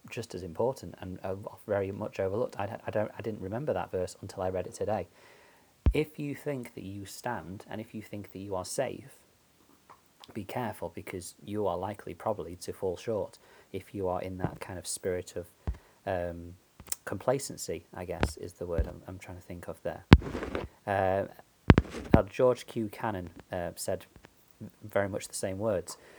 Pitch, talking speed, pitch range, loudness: 95 Hz, 180 wpm, 90-105 Hz, -33 LUFS